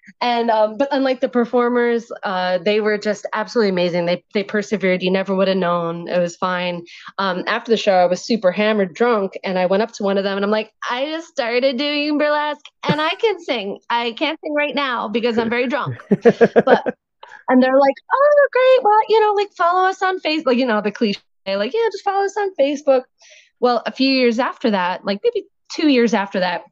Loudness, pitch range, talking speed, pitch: -18 LUFS, 200-285 Hz, 220 wpm, 235 Hz